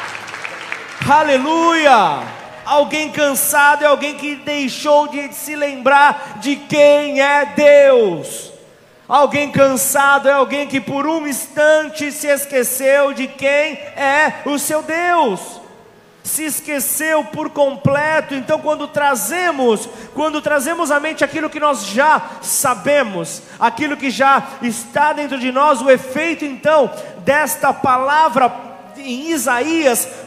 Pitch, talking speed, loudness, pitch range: 285 Hz, 120 wpm, -15 LUFS, 270-300 Hz